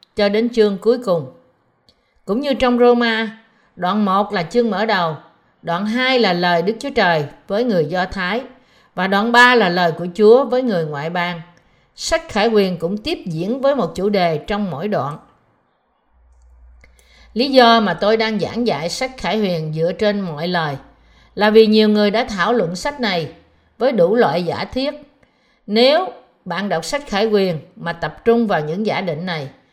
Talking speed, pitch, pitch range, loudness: 185 wpm, 210 Hz, 170-235 Hz, -17 LUFS